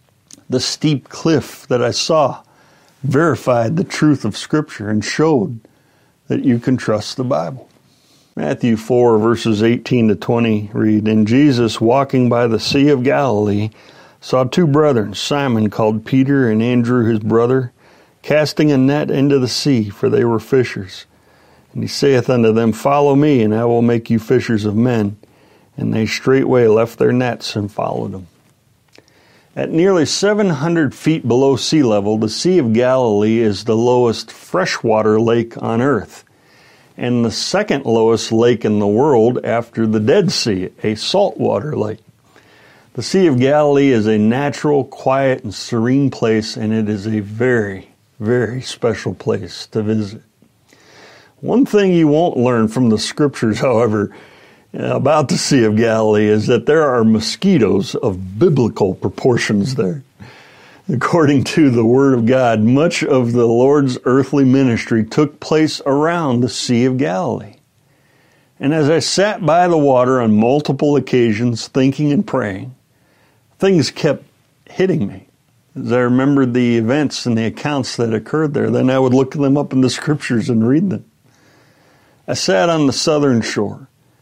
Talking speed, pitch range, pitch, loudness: 155 wpm, 110-140 Hz, 125 Hz, -15 LUFS